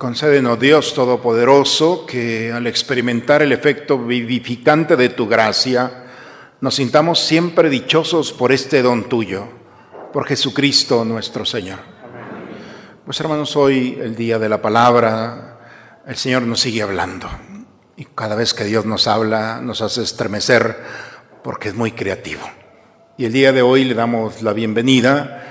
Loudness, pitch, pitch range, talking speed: -16 LUFS, 125 Hz, 115-140 Hz, 140 wpm